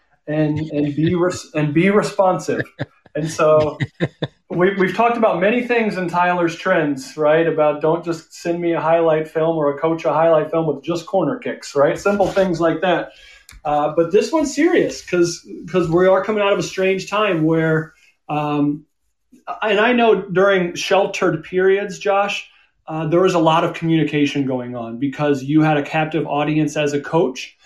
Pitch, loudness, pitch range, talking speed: 165 Hz, -18 LUFS, 150-190 Hz, 180 wpm